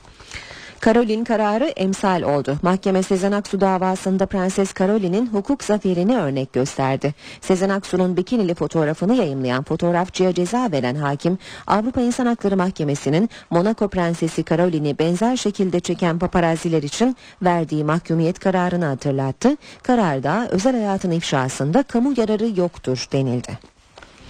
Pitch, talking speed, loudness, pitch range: 180 Hz, 115 wpm, -20 LUFS, 155-205 Hz